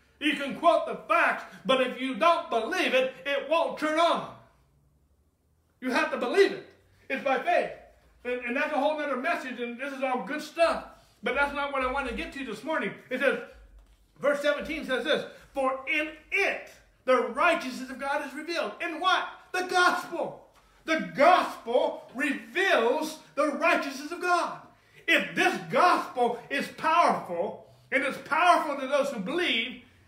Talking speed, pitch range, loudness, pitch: 170 wpm, 255-330 Hz, -27 LUFS, 285 Hz